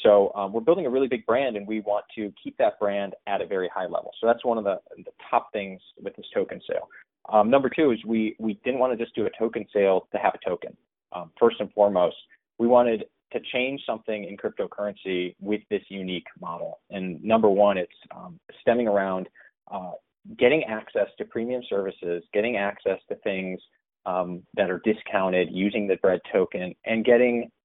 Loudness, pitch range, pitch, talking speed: -25 LUFS, 95-120 Hz, 105 Hz, 200 wpm